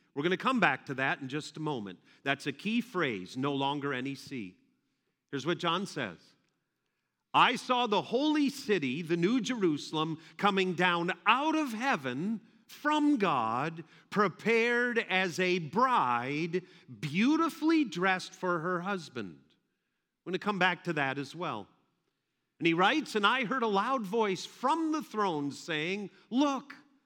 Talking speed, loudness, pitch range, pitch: 155 wpm, -30 LUFS, 160-245 Hz, 185 Hz